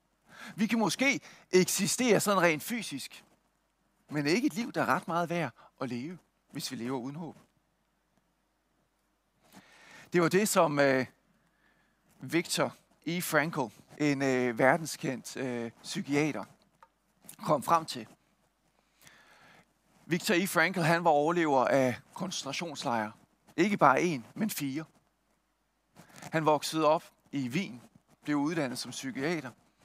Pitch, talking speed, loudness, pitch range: 160 Hz, 125 wpm, -30 LUFS, 140-185 Hz